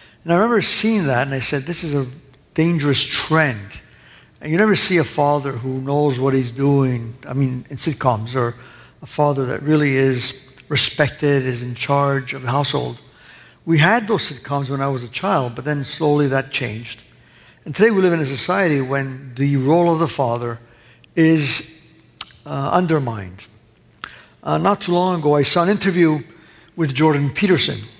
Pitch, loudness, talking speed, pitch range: 140 Hz, -18 LUFS, 180 wpm, 130-160 Hz